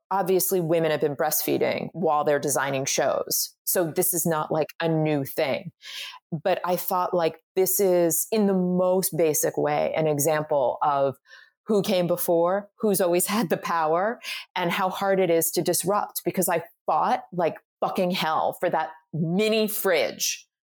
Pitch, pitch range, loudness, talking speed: 175 Hz, 160-190 Hz, -24 LUFS, 160 wpm